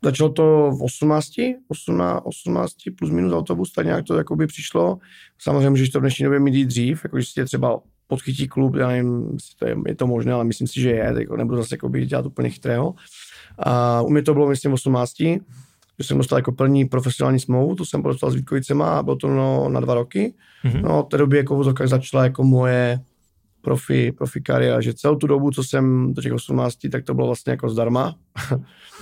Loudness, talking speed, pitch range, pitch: -20 LUFS, 200 wpm, 120-140 Hz, 130 Hz